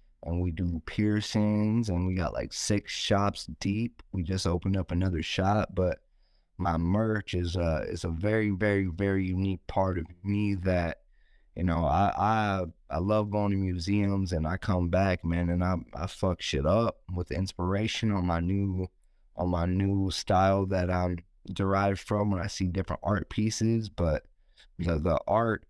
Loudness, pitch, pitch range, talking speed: -29 LUFS, 95 Hz, 90-100 Hz, 175 wpm